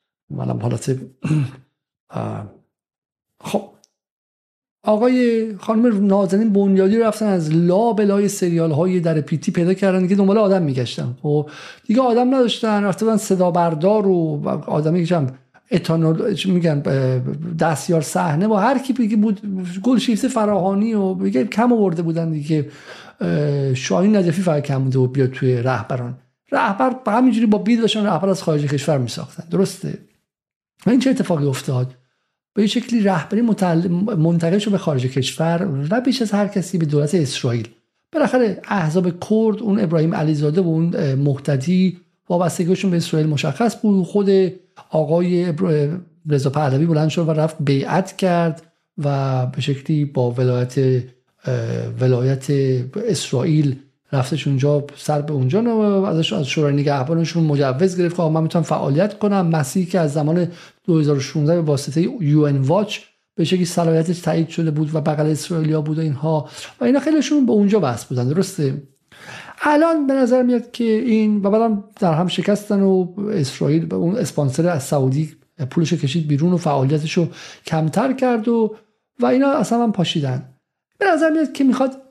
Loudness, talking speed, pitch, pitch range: -18 LUFS, 150 wpm, 170 Hz, 150-205 Hz